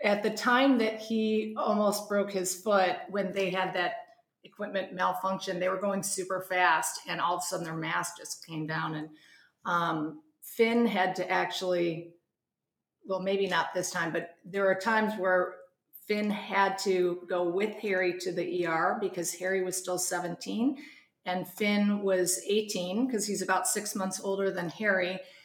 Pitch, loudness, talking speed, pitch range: 190 Hz, -30 LUFS, 170 wpm, 180-205 Hz